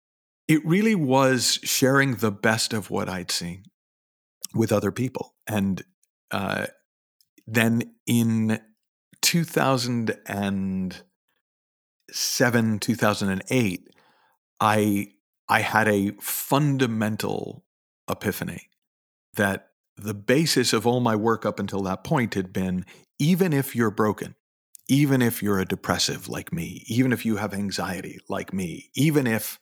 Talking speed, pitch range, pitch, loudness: 120 wpm, 100-130 Hz, 110 Hz, -24 LUFS